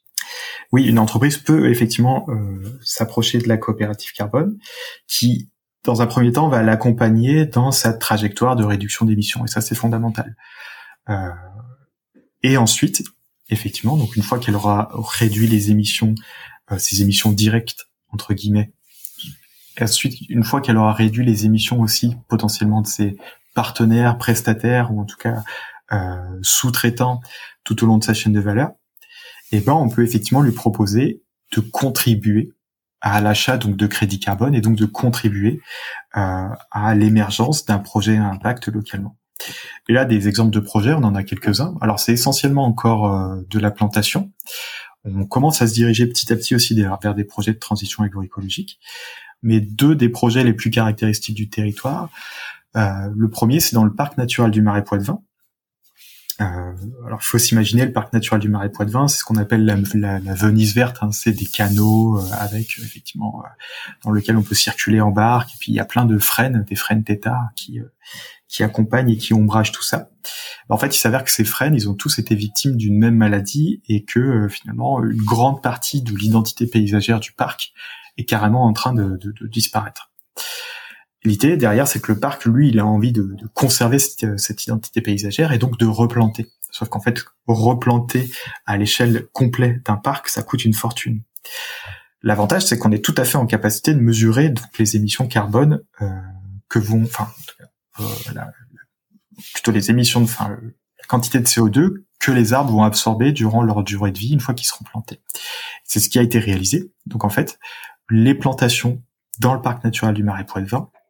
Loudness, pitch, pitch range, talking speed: -18 LUFS, 115 Hz, 105-125 Hz, 185 wpm